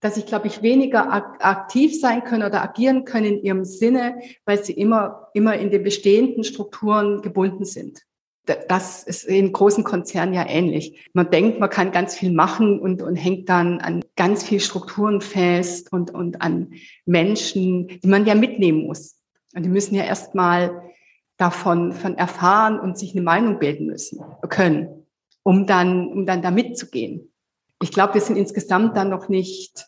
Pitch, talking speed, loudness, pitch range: 195 Hz, 170 wpm, -20 LUFS, 180-210 Hz